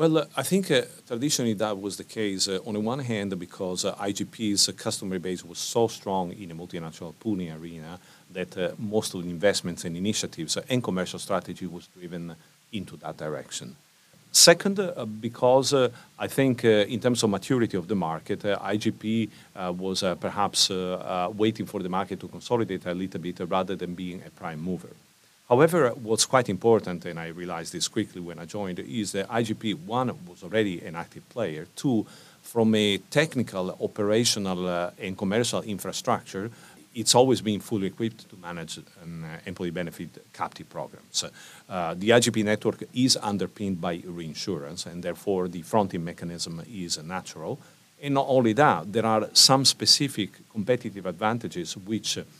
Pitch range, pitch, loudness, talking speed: 90-115 Hz, 100 Hz, -26 LUFS, 175 wpm